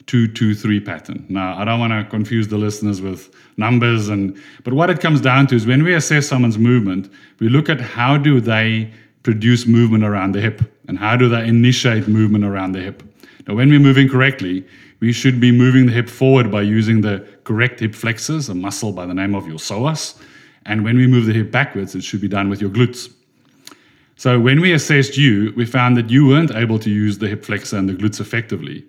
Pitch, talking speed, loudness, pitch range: 115 Hz, 220 wpm, -16 LUFS, 105-125 Hz